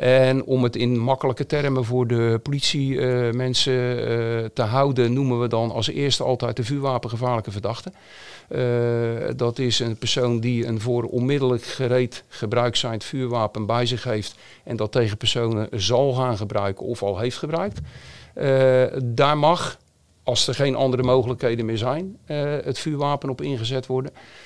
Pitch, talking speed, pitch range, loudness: 125 Hz, 155 wpm, 115-130 Hz, -22 LUFS